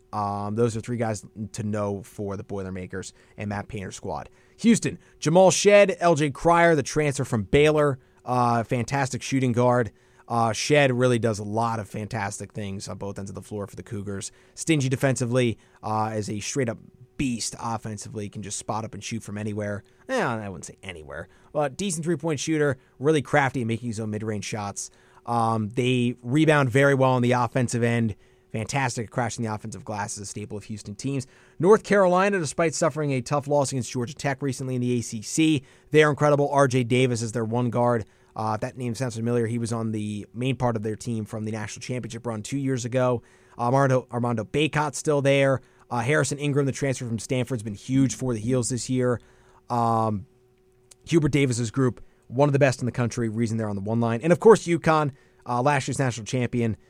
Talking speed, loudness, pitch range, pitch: 200 wpm, -24 LUFS, 110-135 Hz, 125 Hz